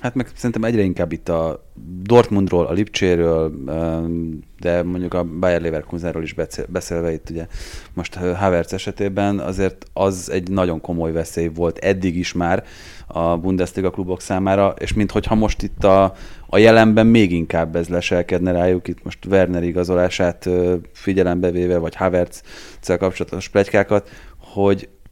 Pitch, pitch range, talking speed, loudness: 90 Hz, 85-95 Hz, 140 wpm, -19 LUFS